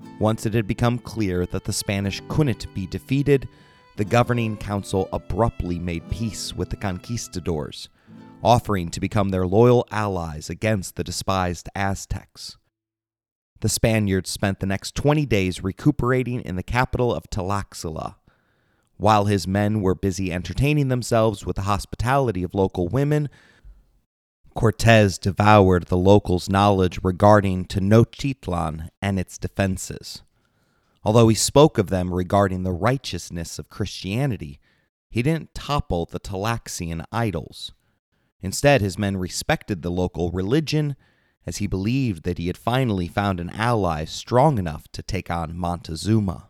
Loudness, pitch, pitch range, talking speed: -22 LUFS, 100 Hz, 90-115 Hz, 135 wpm